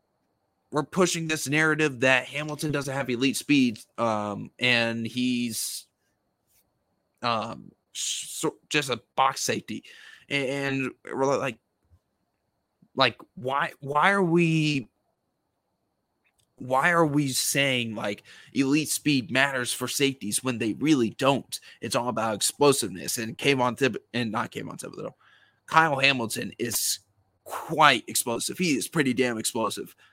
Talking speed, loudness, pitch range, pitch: 135 wpm, -25 LUFS, 120-150 Hz, 135 Hz